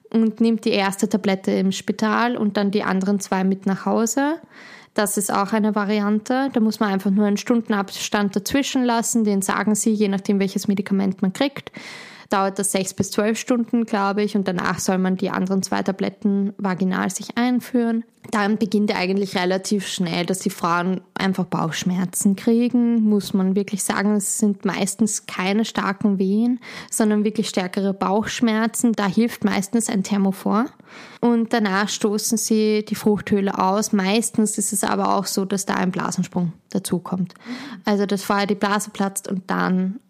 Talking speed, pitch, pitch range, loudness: 170 wpm, 205 Hz, 195-220 Hz, -21 LUFS